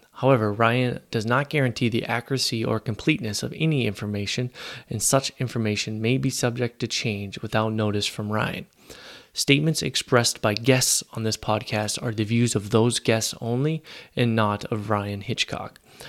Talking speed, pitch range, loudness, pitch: 160 wpm, 110-130 Hz, -24 LUFS, 115 Hz